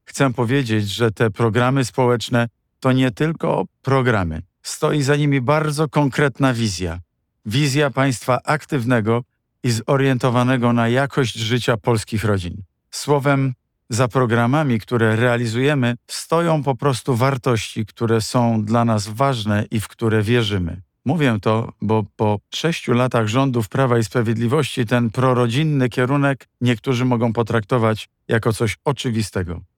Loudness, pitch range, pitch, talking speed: -19 LUFS, 110-135 Hz, 125 Hz, 125 wpm